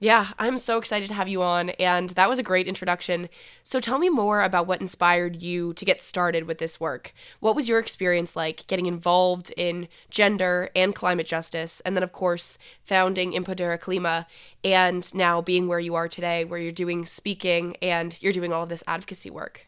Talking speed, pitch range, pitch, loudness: 200 wpm, 170-190 Hz, 180 Hz, -24 LUFS